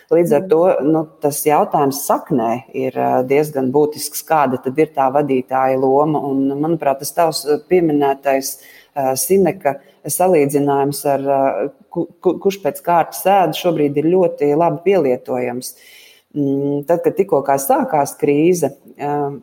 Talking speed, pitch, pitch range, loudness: 105 wpm, 145 Hz, 135-165 Hz, -17 LUFS